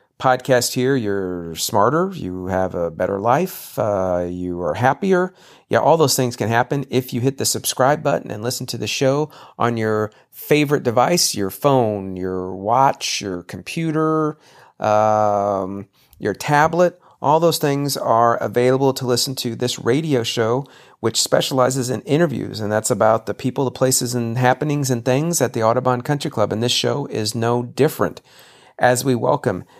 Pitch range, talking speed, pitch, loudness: 110-140 Hz, 165 wpm, 125 Hz, -19 LUFS